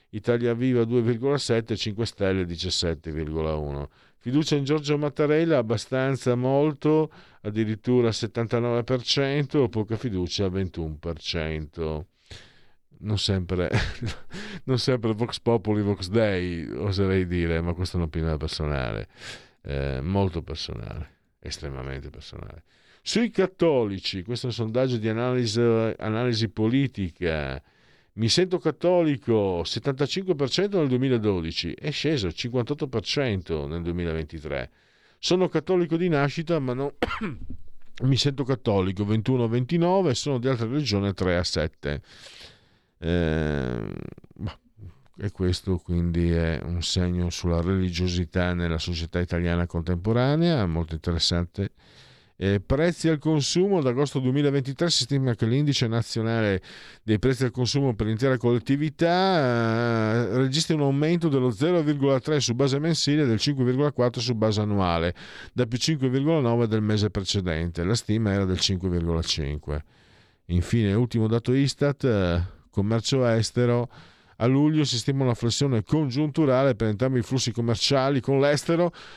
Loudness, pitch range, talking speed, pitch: -25 LUFS, 90-140 Hz, 115 wpm, 115 Hz